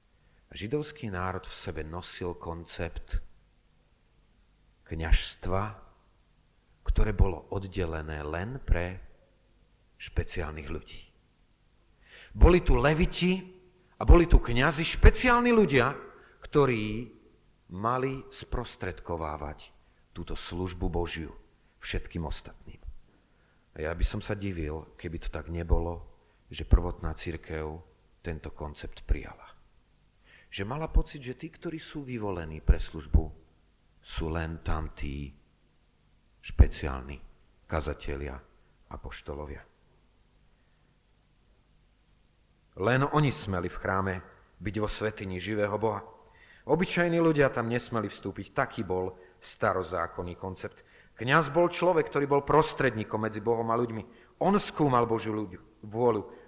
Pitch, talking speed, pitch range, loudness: 95 Hz, 105 wpm, 80-120 Hz, -30 LUFS